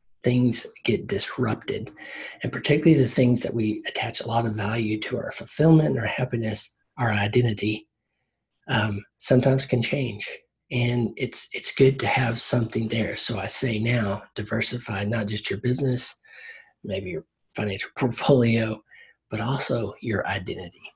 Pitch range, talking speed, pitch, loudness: 110-130 Hz, 145 wpm, 120 Hz, -25 LUFS